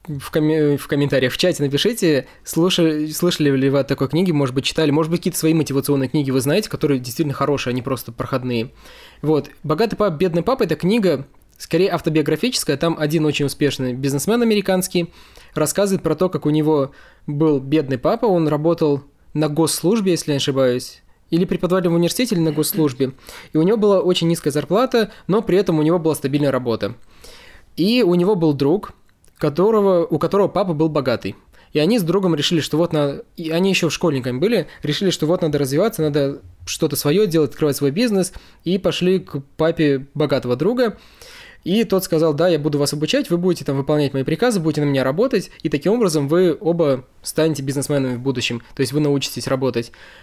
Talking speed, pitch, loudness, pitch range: 190 wpm, 155 Hz, -19 LUFS, 140-175 Hz